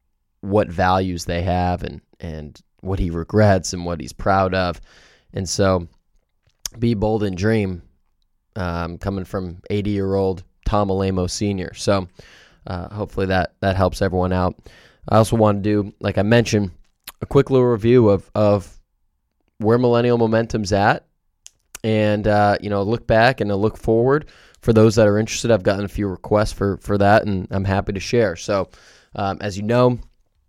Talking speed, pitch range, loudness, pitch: 170 wpm, 90-110 Hz, -19 LUFS, 100 Hz